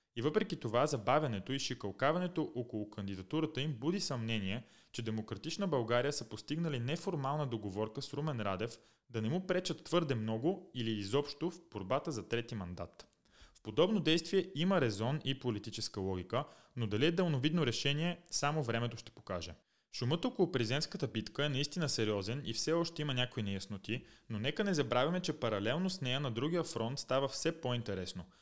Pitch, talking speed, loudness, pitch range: 130 Hz, 165 wpm, -36 LUFS, 110-155 Hz